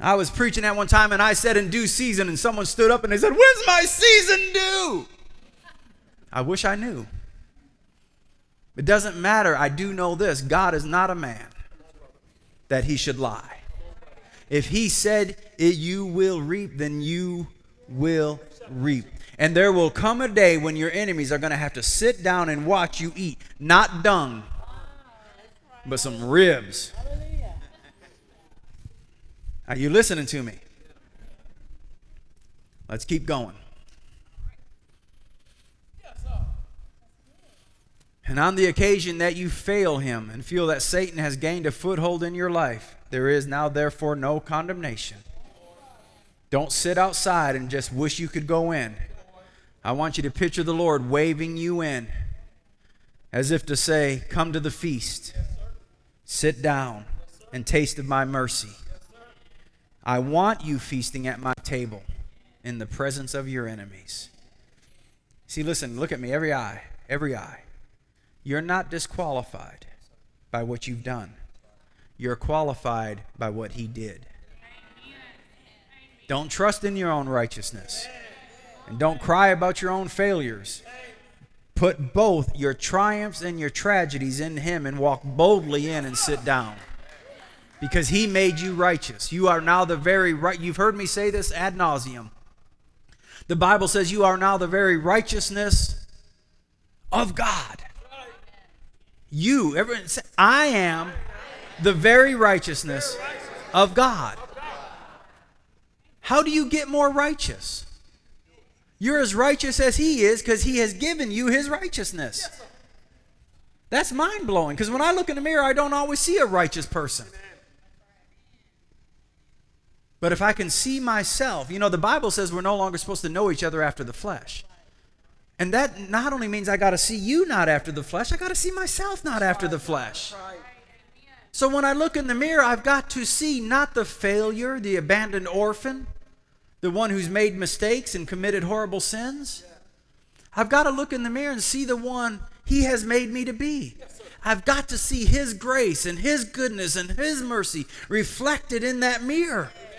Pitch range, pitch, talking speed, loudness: 135-215 Hz, 175 Hz, 155 wpm, -23 LUFS